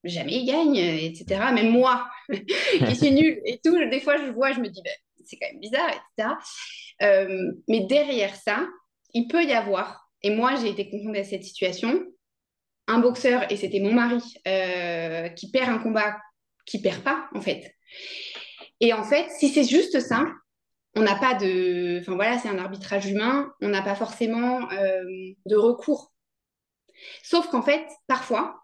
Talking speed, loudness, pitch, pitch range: 180 wpm, -24 LUFS, 230 Hz, 195-270 Hz